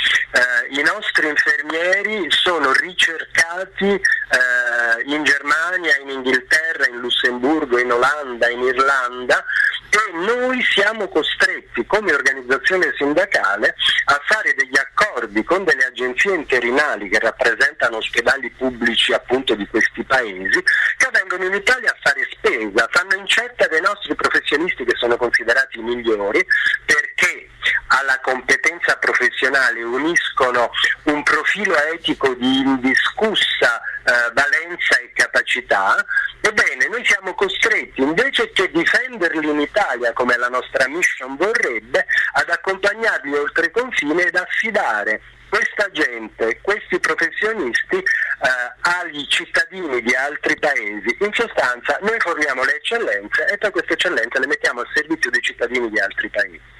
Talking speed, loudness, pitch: 125 wpm, -17 LUFS, 210 Hz